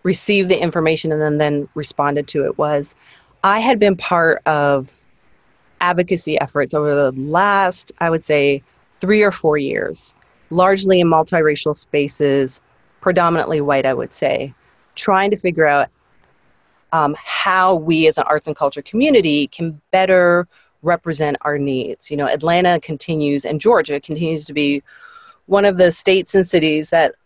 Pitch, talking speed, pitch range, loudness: 160 Hz, 155 wpm, 145-180 Hz, -16 LUFS